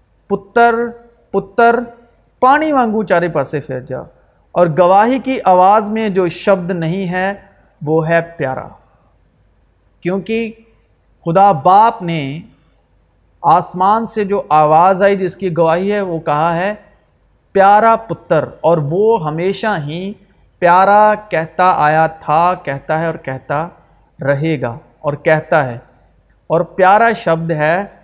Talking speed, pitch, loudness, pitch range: 125 wpm, 180 Hz, -14 LUFS, 160-205 Hz